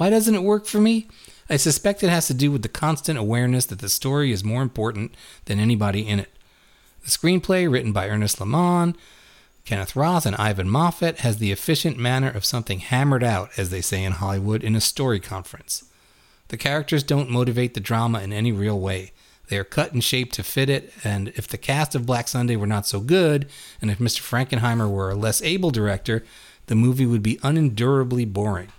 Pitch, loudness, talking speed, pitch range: 120 Hz, -22 LUFS, 205 wpm, 105-145 Hz